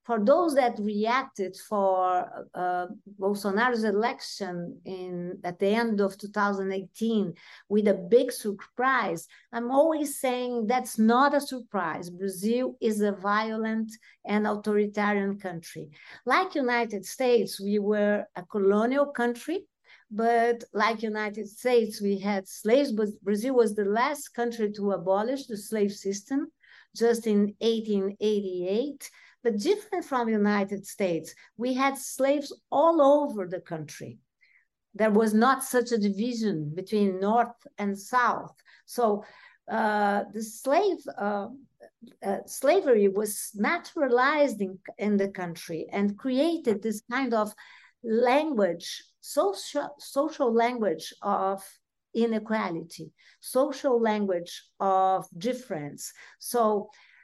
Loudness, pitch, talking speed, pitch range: -27 LUFS, 215 Hz, 120 wpm, 200-250 Hz